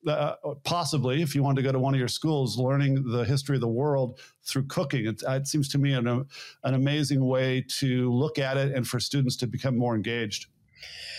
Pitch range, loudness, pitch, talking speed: 125-140 Hz, -27 LUFS, 135 Hz, 215 wpm